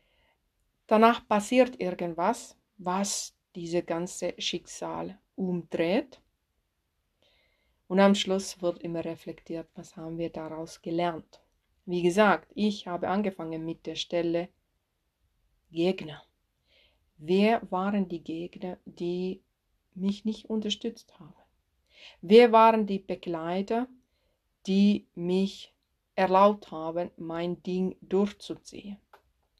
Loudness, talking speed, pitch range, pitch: -28 LUFS, 95 wpm, 170-205 Hz, 185 Hz